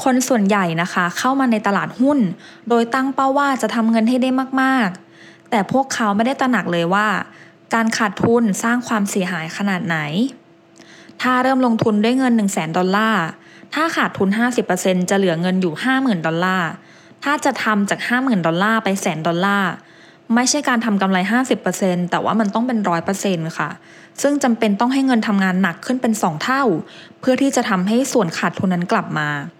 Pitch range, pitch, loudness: 185-250 Hz, 220 Hz, -18 LUFS